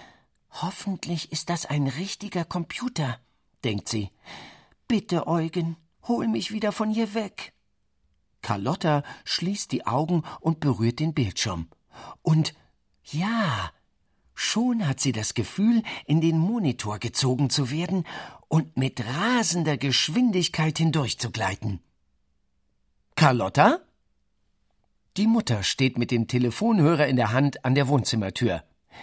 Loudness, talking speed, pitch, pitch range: -25 LUFS, 115 wpm, 150 Hz, 120-175 Hz